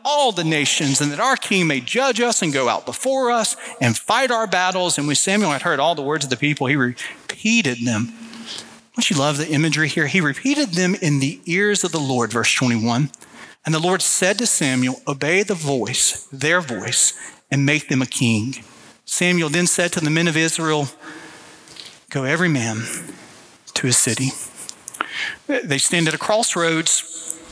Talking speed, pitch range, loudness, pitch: 185 wpm, 140-185 Hz, -19 LUFS, 160 Hz